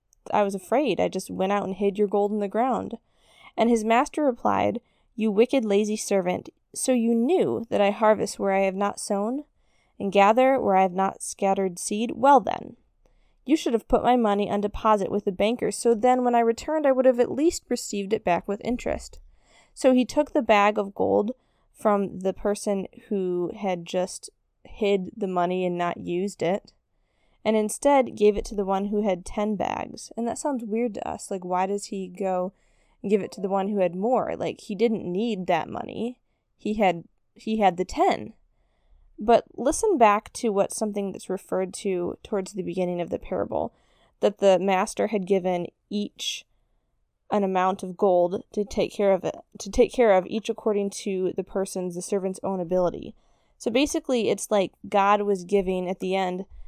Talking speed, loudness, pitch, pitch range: 195 wpm, -25 LUFS, 205 Hz, 190-230 Hz